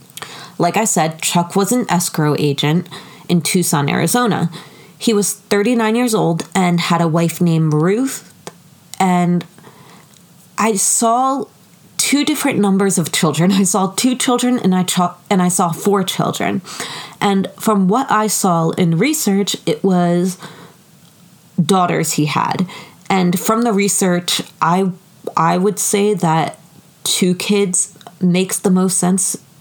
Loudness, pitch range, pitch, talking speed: -16 LUFS, 170-205 Hz, 185 Hz, 140 wpm